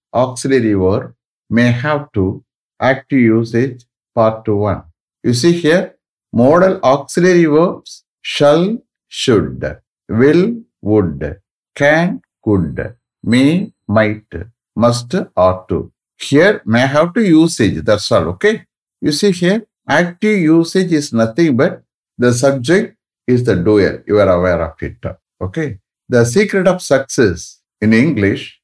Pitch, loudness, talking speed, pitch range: 130 Hz, -14 LUFS, 125 wpm, 110-165 Hz